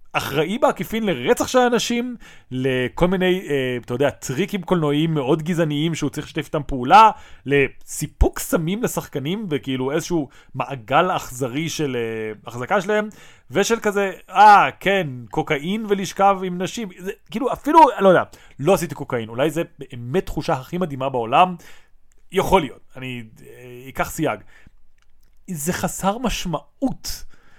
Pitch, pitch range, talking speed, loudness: 160 Hz, 135-195 Hz, 135 wpm, -20 LUFS